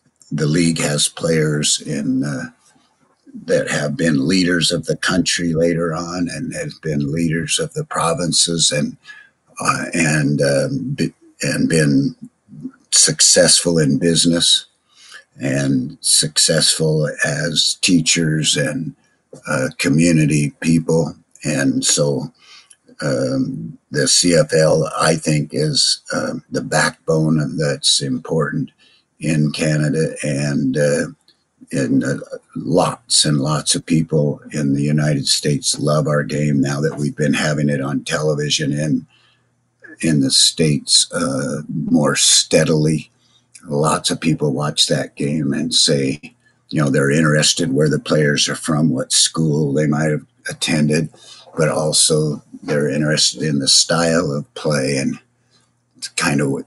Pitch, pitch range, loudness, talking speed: 75 Hz, 75-80 Hz, -16 LUFS, 130 wpm